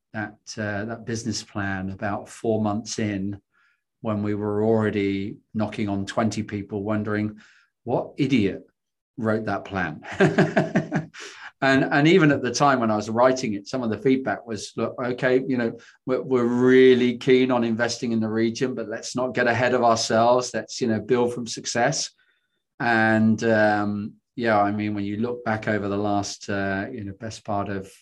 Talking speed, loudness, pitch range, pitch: 180 wpm, -23 LUFS, 105-120 Hz, 110 Hz